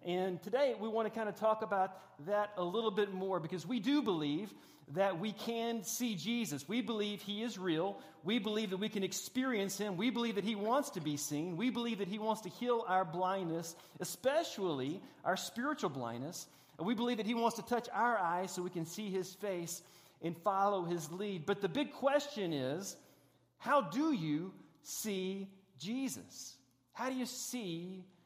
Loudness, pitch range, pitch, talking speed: -37 LUFS, 180-230 Hz, 200 Hz, 190 wpm